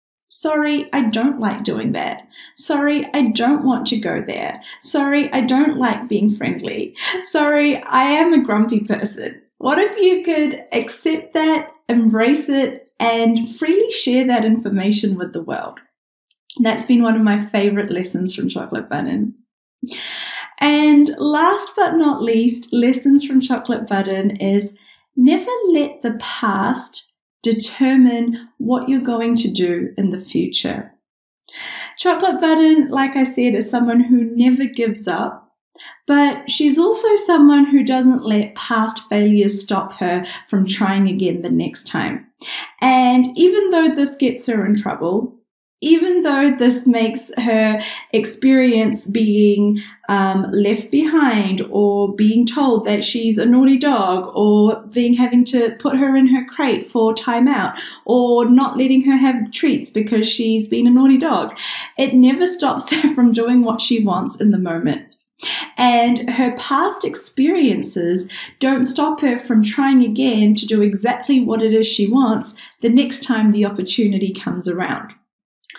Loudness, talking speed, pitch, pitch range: -16 LUFS, 150 wpm, 245 Hz, 220-280 Hz